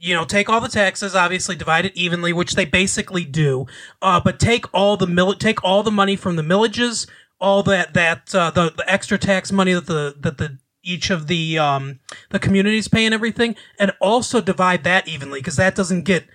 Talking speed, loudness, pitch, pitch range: 215 wpm, -18 LUFS, 185 Hz, 170-200 Hz